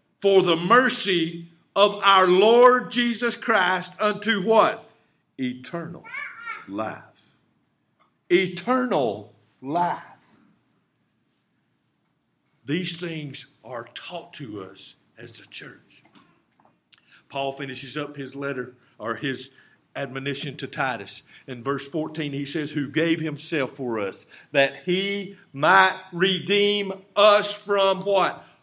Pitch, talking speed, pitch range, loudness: 170 Hz, 105 wpm, 140-200 Hz, -22 LUFS